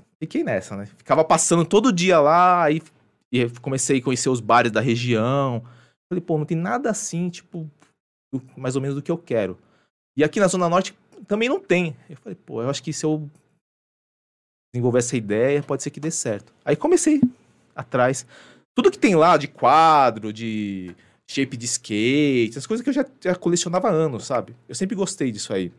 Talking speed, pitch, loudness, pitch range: 195 wpm, 145 Hz, -21 LUFS, 125-180 Hz